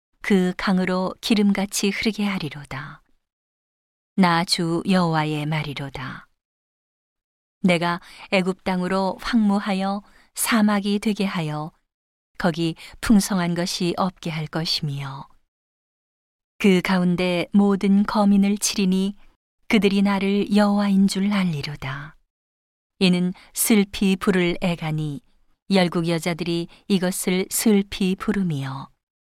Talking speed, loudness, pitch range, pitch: 215 characters per minute, -22 LUFS, 165-200 Hz, 185 Hz